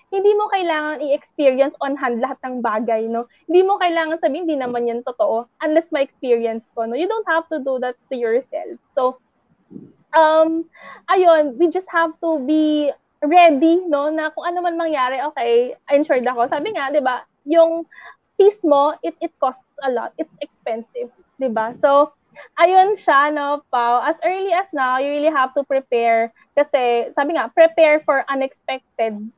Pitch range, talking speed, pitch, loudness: 255-330 Hz, 175 wpm, 290 Hz, -18 LUFS